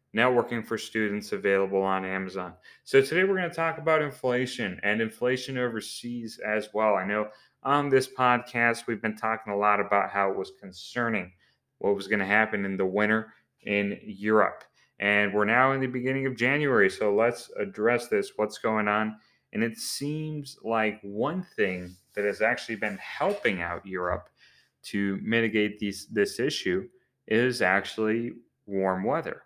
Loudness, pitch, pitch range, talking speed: -27 LUFS, 110 Hz, 100-125 Hz, 165 wpm